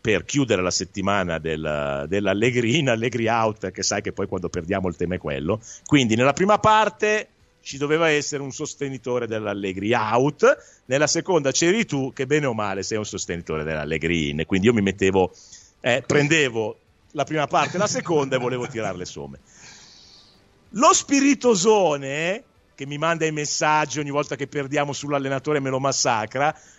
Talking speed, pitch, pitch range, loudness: 170 wpm, 130 Hz, 95-150 Hz, -22 LUFS